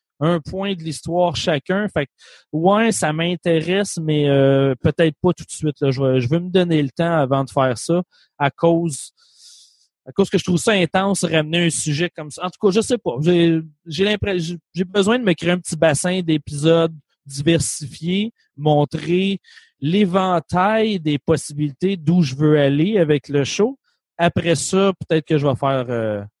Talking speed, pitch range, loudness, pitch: 190 wpm, 150-180 Hz, -19 LUFS, 165 Hz